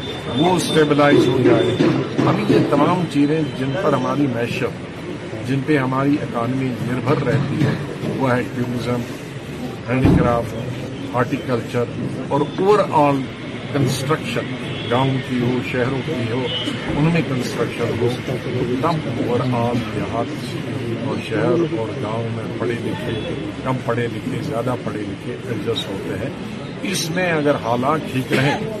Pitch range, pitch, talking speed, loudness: 120-145 Hz, 130 Hz, 140 wpm, -20 LUFS